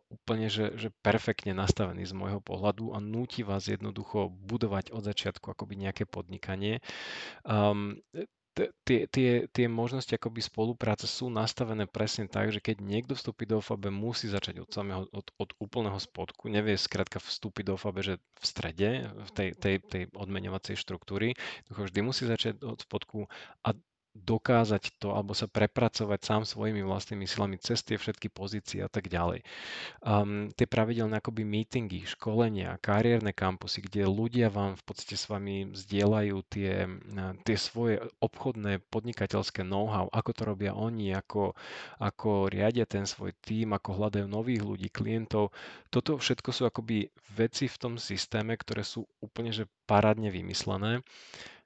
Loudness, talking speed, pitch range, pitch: -32 LUFS, 150 wpm, 100-115 Hz, 105 Hz